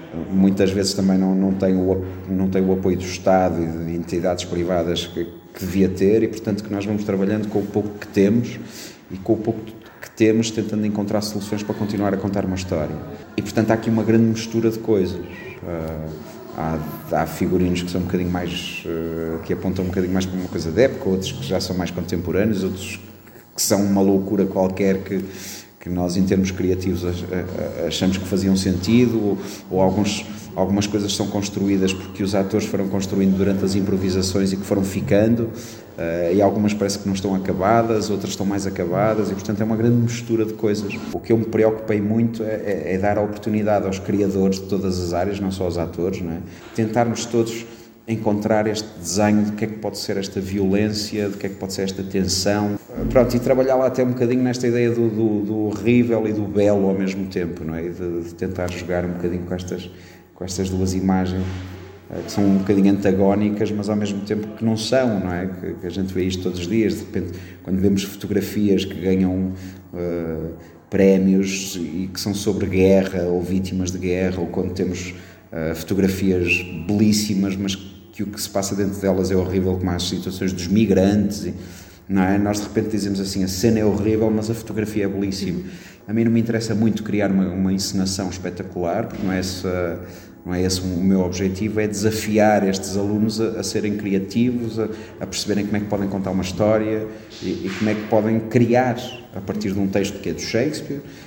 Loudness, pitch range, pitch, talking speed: -21 LUFS, 95-105 Hz, 100 Hz, 205 wpm